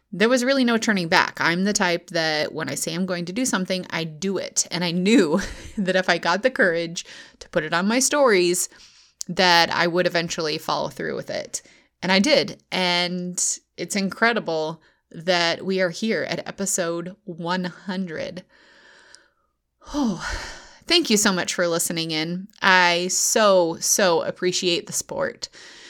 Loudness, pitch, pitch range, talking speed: -21 LUFS, 180 Hz, 170-205 Hz, 165 wpm